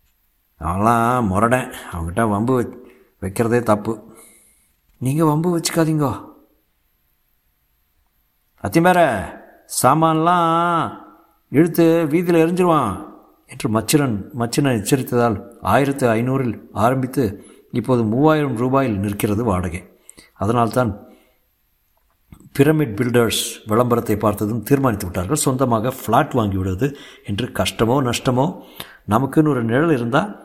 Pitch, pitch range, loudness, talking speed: 125 Hz, 105-145 Hz, -18 LUFS, 85 wpm